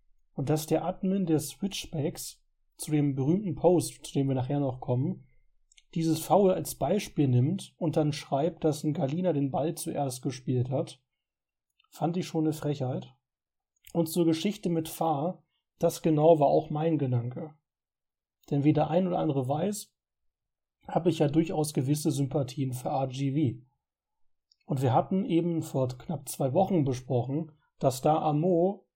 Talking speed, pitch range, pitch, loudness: 160 wpm, 140-170 Hz, 155 Hz, -29 LUFS